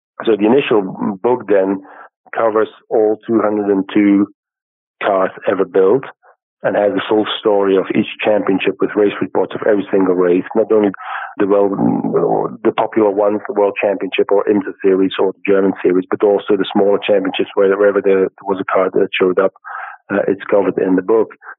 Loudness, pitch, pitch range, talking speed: -15 LUFS, 100 Hz, 95-105 Hz, 180 wpm